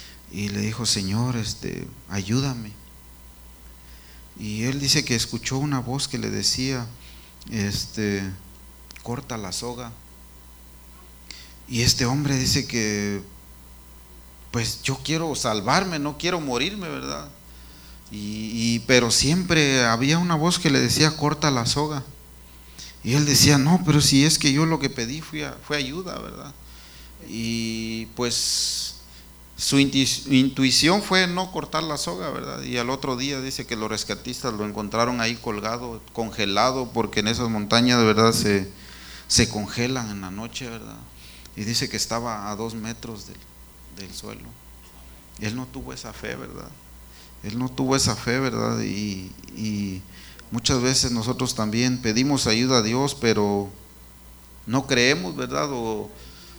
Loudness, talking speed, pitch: -23 LUFS, 145 wpm, 115 Hz